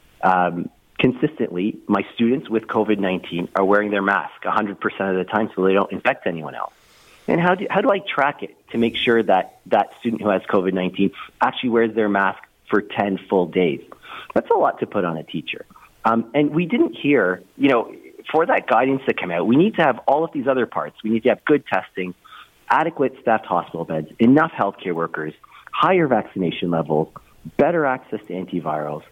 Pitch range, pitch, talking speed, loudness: 90-115 Hz, 105 Hz, 205 wpm, -20 LUFS